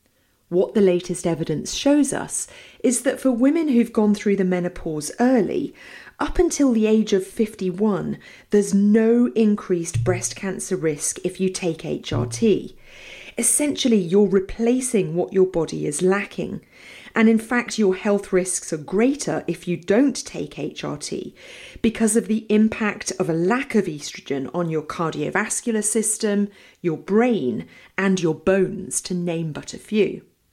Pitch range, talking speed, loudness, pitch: 180-225 Hz, 150 wpm, -21 LUFS, 200 Hz